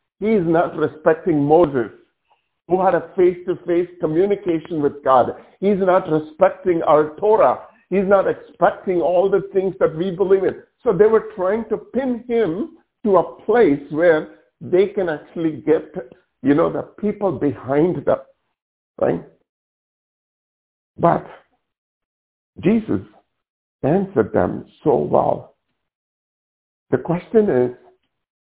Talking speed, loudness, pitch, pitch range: 120 wpm, -19 LUFS, 180 Hz, 155-200 Hz